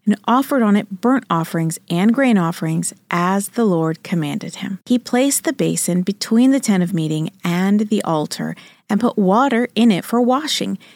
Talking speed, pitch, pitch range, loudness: 180 wpm, 205 Hz, 175-235 Hz, -18 LUFS